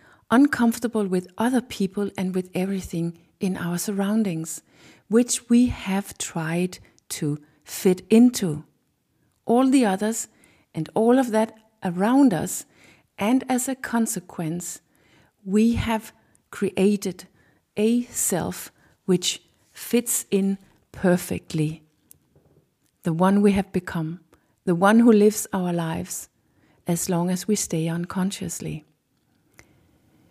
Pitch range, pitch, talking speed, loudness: 175-220 Hz, 195 Hz, 110 wpm, -23 LUFS